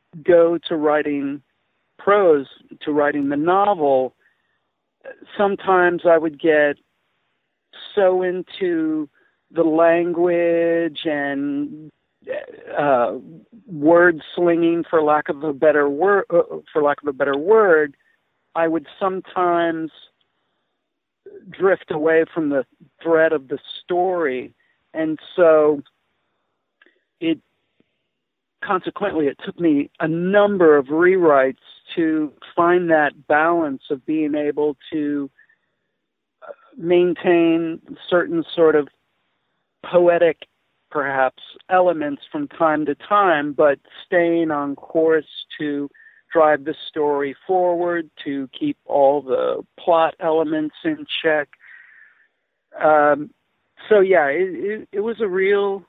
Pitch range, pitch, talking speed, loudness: 150-190 Hz, 165 Hz, 105 wpm, -19 LUFS